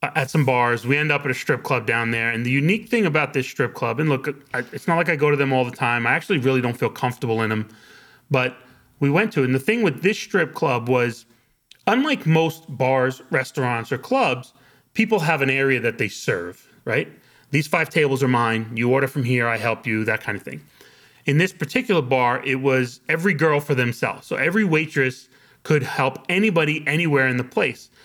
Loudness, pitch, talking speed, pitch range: -21 LUFS, 135 Hz, 220 wpm, 125-160 Hz